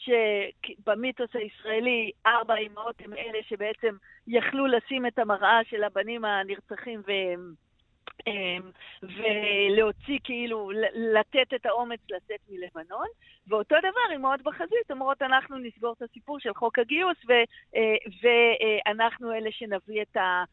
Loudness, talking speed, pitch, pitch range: -27 LUFS, 115 wpm, 225 Hz, 210-245 Hz